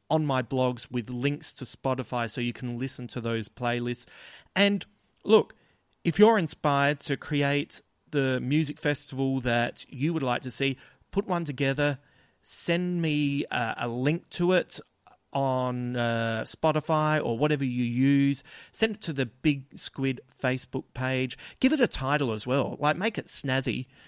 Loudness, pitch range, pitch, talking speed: -28 LUFS, 125-155 Hz, 135 Hz, 160 wpm